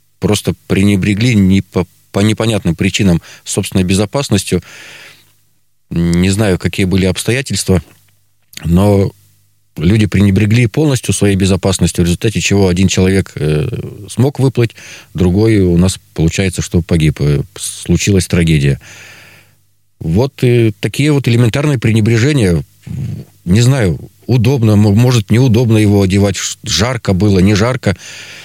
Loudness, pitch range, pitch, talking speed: -12 LUFS, 95-115 Hz, 100 Hz, 110 wpm